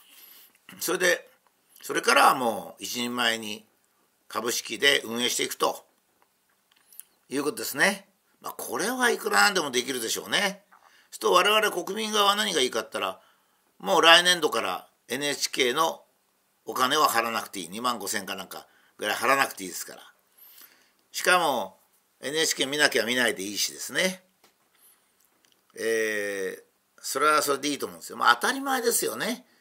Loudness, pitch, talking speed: -25 LUFS, 195 Hz, 320 characters per minute